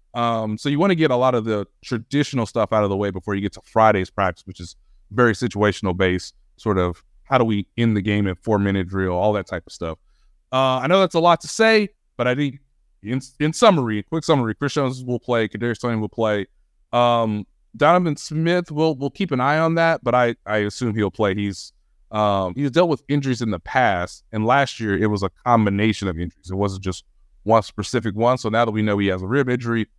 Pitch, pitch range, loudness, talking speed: 110 Hz, 100-130 Hz, -20 LUFS, 235 wpm